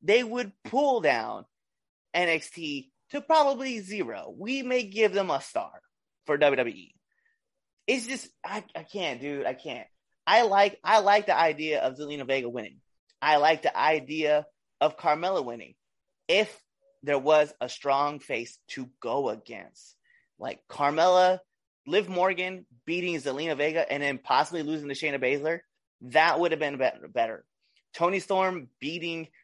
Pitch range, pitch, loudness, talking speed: 145-205 Hz, 165 Hz, -27 LUFS, 145 wpm